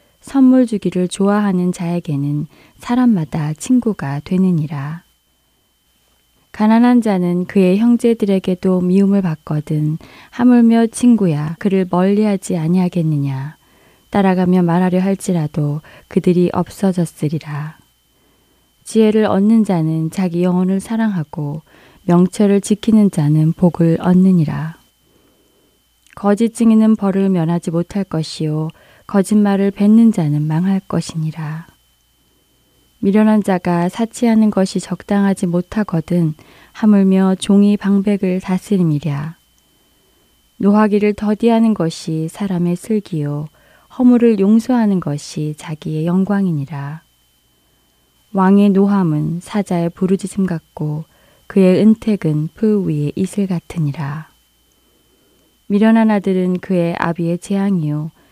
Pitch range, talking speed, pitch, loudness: 160-205 Hz, 255 characters per minute, 180 Hz, -15 LUFS